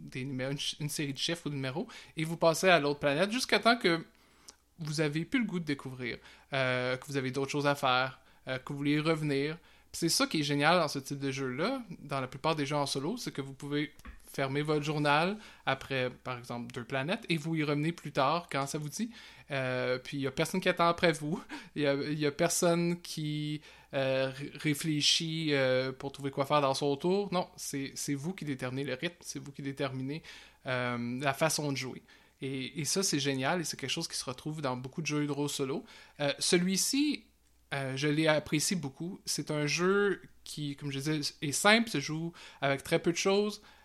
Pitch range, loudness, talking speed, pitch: 135-170 Hz, -32 LUFS, 230 wpm, 150 Hz